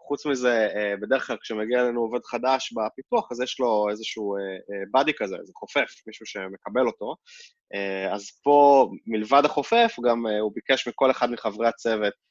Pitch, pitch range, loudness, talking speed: 120 Hz, 105-135 Hz, -24 LUFS, 150 wpm